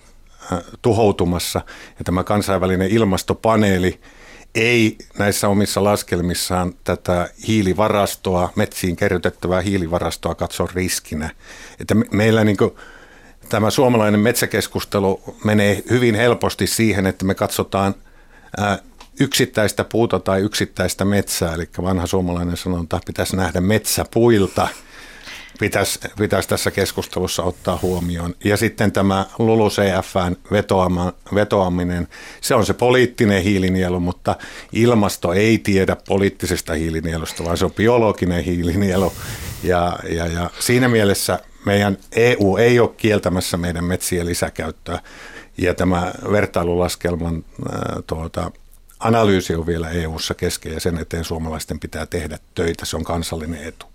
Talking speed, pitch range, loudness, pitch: 120 wpm, 85-105 Hz, -19 LUFS, 95 Hz